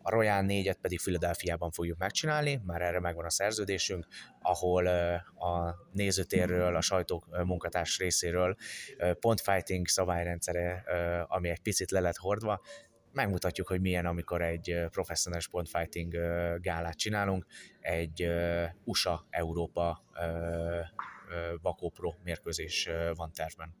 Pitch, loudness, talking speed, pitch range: 90 Hz, -33 LUFS, 105 wpm, 85-95 Hz